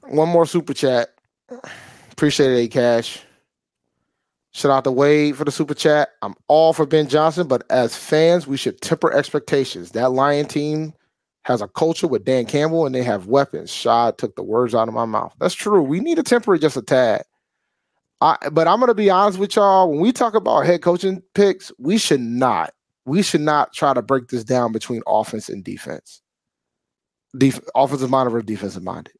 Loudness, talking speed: -18 LUFS, 190 wpm